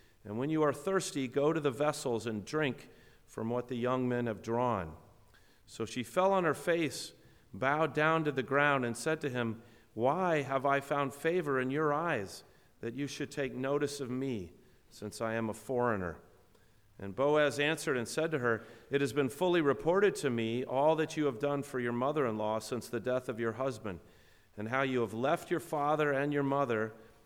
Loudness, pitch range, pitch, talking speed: -33 LUFS, 115-145 Hz, 135 Hz, 205 wpm